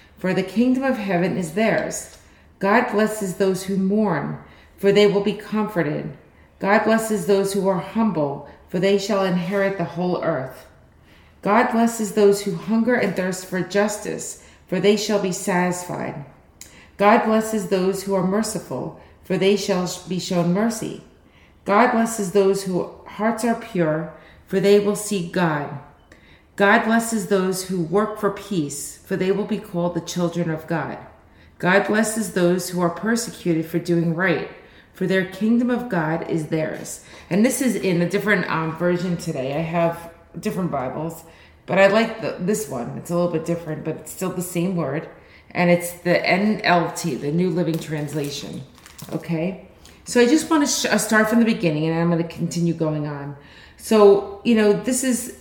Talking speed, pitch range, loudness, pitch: 175 wpm, 170-210 Hz, -21 LUFS, 185 Hz